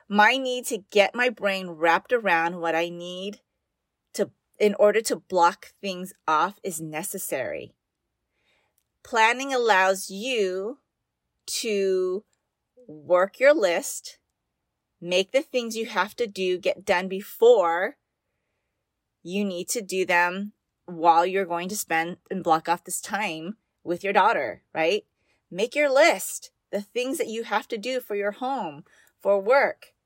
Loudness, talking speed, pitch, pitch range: -24 LUFS, 140 wpm, 200 Hz, 180-235 Hz